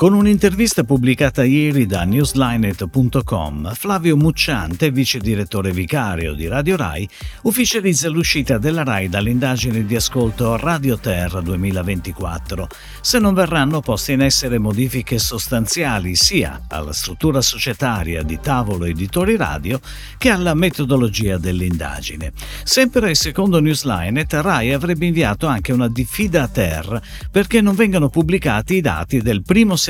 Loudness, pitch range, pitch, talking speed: -17 LUFS, 100-165 Hz, 130 Hz, 130 wpm